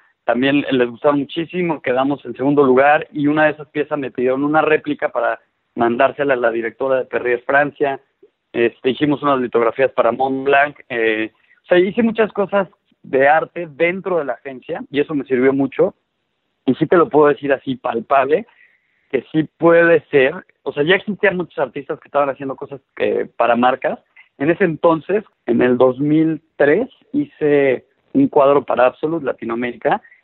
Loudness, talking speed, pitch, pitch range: -17 LUFS, 170 wpm, 145 Hz, 130-160 Hz